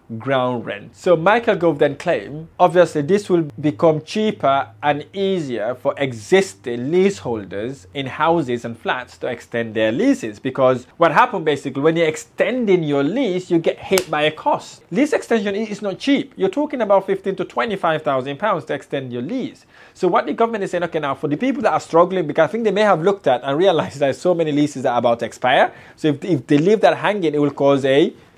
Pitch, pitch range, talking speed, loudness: 160 Hz, 140-195 Hz, 210 wpm, -19 LUFS